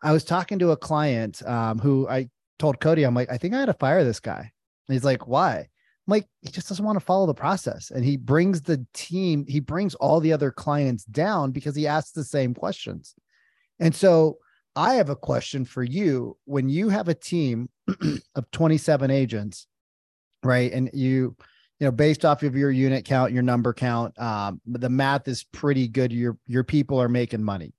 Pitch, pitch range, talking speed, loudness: 135 Hz, 125-155 Hz, 205 wpm, -24 LUFS